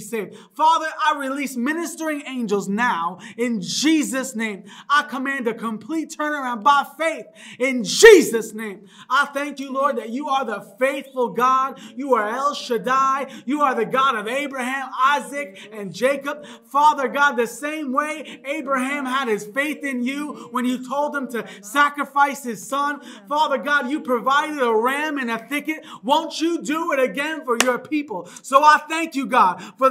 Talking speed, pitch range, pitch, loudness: 170 wpm, 235-290 Hz, 270 Hz, -20 LUFS